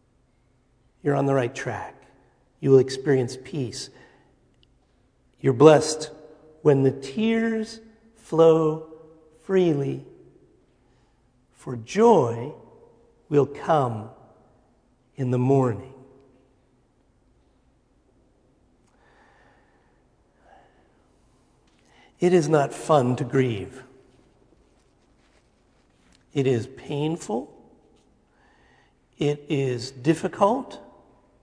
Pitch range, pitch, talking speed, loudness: 130-160 Hz, 135 Hz, 65 wpm, -23 LUFS